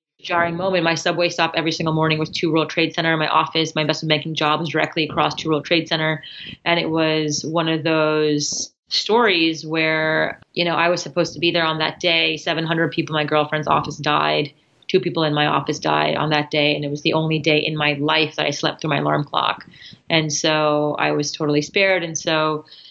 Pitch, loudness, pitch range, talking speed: 155 Hz, -19 LUFS, 150-165 Hz, 230 wpm